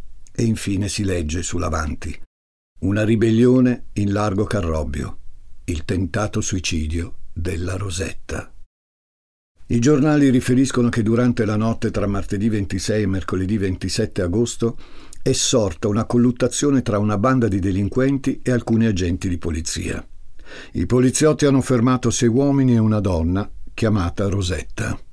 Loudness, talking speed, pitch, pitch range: -20 LUFS, 130 wpm, 105 Hz, 90-120 Hz